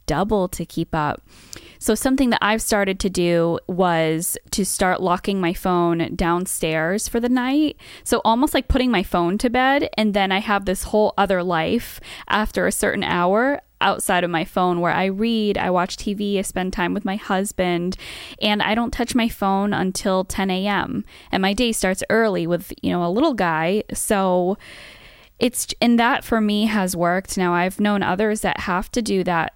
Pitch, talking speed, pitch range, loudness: 195 Hz, 190 wpm, 180-225 Hz, -20 LUFS